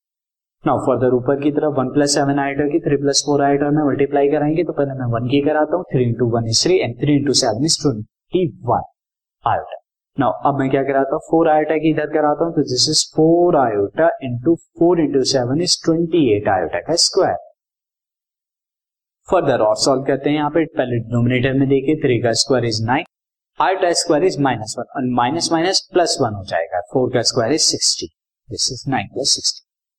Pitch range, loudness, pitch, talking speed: 125-155 Hz, -17 LUFS, 140 Hz, 145 wpm